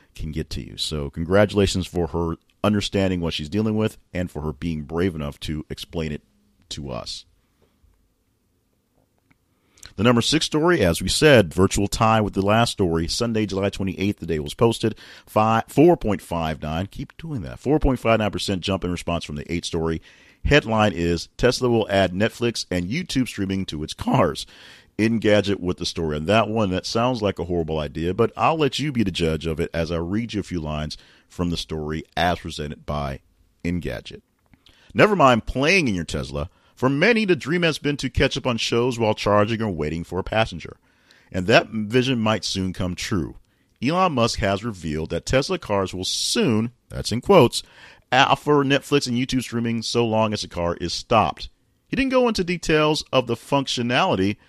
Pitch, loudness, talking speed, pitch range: 100 Hz, -22 LUFS, 195 wpm, 85-115 Hz